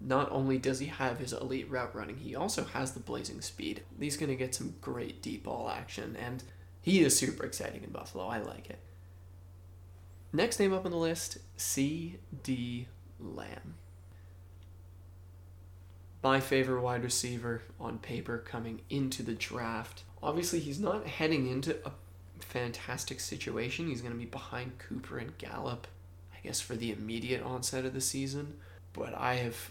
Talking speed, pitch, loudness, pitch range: 160 wpm, 115 Hz, -35 LUFS, 90-130 Hz